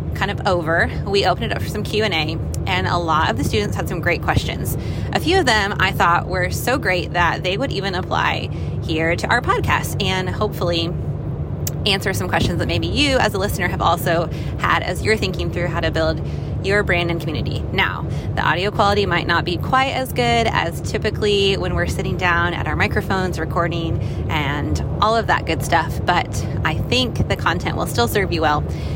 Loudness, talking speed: -19 LUFS, 205 wpm